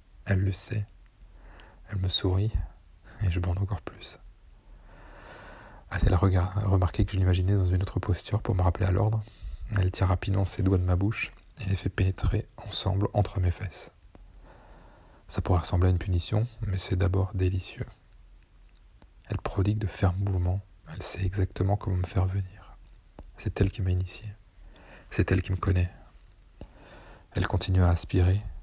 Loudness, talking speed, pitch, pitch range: -28 LUFS, 165 wpm, 95 Hz, 90-100 Hz